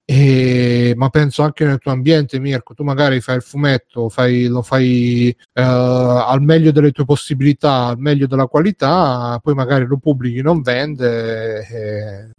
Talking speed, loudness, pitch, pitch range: 145 wpm, -15 LUFS, 130 Hz, 125-145 Hz